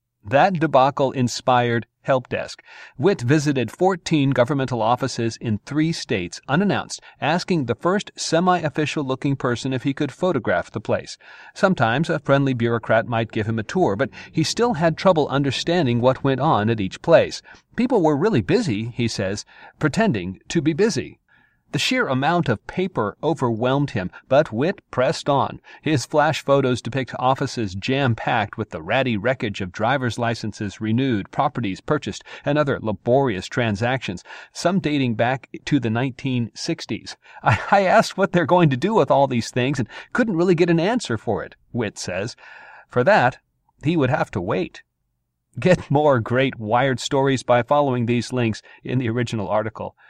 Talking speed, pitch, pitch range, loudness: 165 wpm, 130 Hz, 115-155 Hz, -21 LUFS